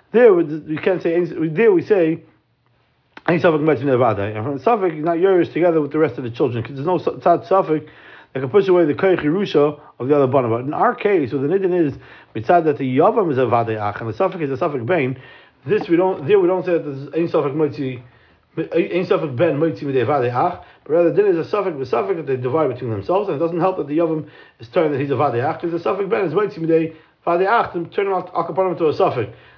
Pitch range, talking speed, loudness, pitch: 135-180 Hz, 245 wpm, -18 LUFS, 160 Hz